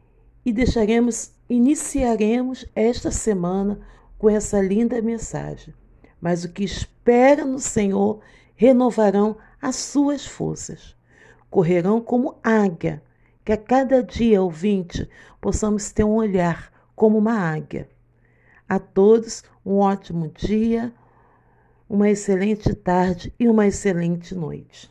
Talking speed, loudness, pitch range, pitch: 110 wpm, -20 LUFS, 185-230 Hz, 210 Hz